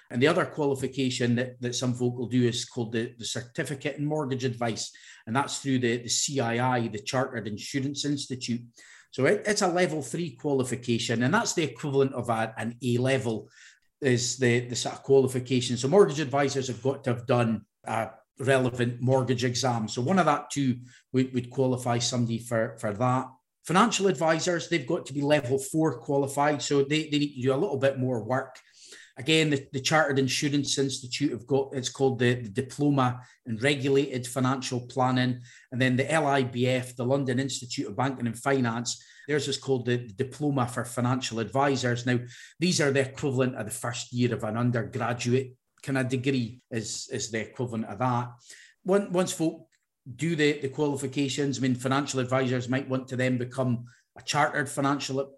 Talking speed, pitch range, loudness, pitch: 185 wpm, 120-140 Hz, -27 LUFS, 130 Hz